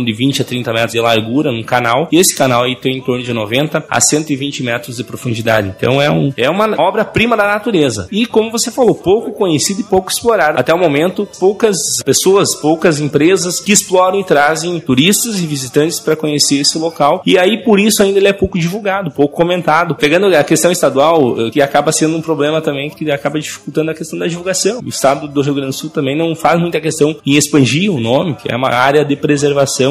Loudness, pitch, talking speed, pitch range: -13 LUFS, 155 Hz, 215 wpm, 140-185 Hz